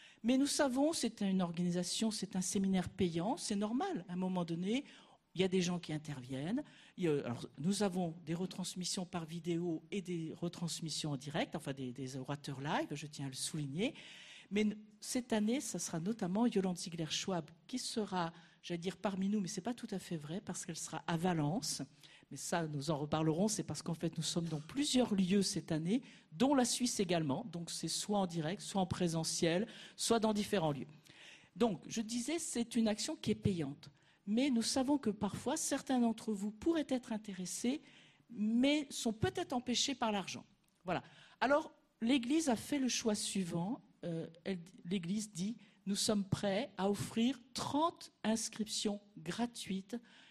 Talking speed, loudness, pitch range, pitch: 180 wpm, -37 LUFS, 170-235 Hz, 195 Hz